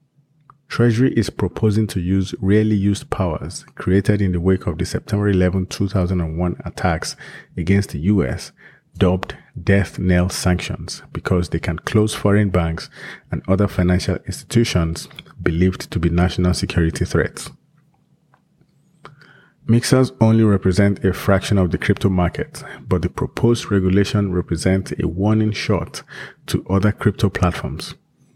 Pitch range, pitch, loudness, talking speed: 90-110 Hz, 100 Hz, -19 LUFS, 130 wpm